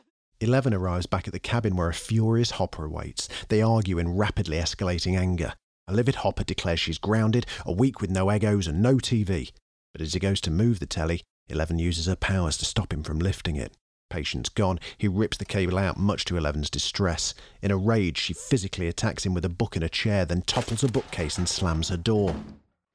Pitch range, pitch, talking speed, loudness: 85-110 Hz, 95 Hz, 210 wpm, -26 LUFS